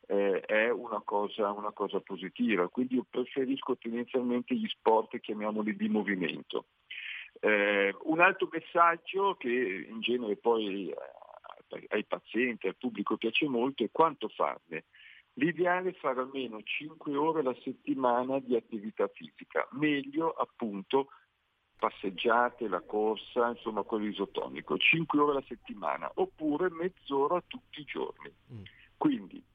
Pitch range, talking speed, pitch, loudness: 110-165 Hz, 125 wpm, 125 Hz, -31 LUFS